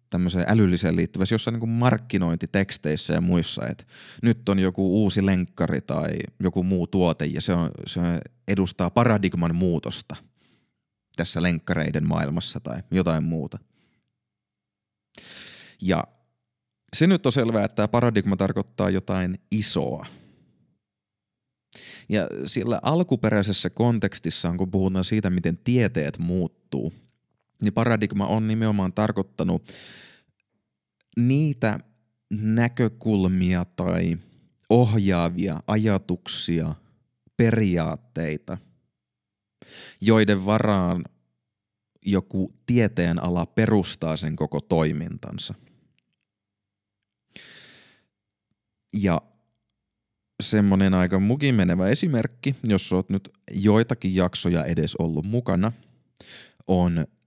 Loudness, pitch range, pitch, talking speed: -24 LUFS, 90-110 Hz, 100 Hz, 90 wpm